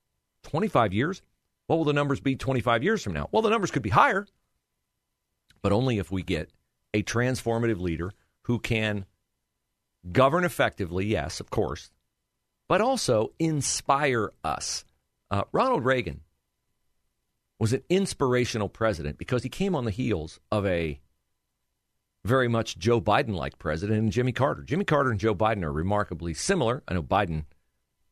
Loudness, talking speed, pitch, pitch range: -26 LUFS, 150 wpm, 110 Hz, 90-130 Hz